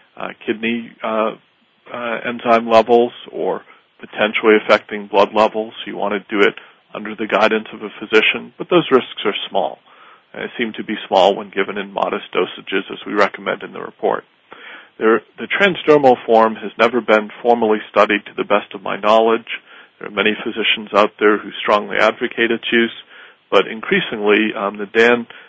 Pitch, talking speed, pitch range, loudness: 110 Hz, 175 wpm, 105-120 Hz, -17 LUFS